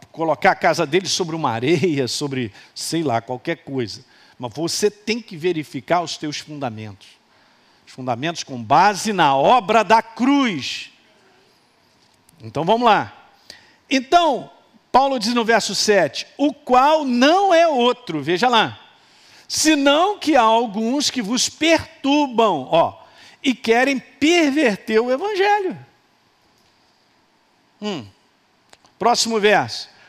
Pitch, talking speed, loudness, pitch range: 220 Hz, 120 wpm, -18 LUFS, 165-270 Hz